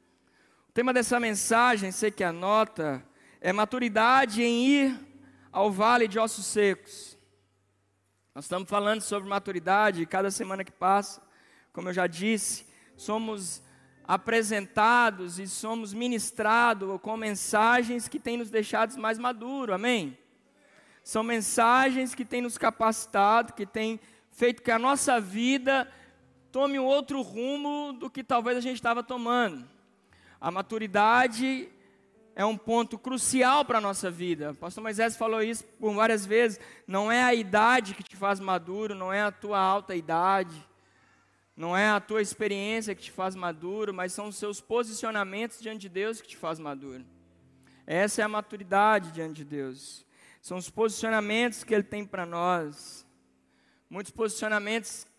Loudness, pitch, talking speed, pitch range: -27 LUFS, 215 Hz, 150 wpm, 190-235 Hz